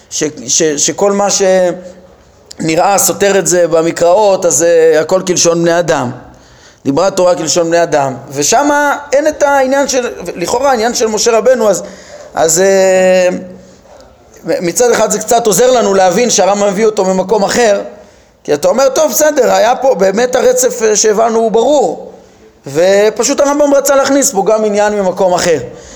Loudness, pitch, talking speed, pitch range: -10 LUFS, 200 Hz, 155 wpm, 175-250 Hz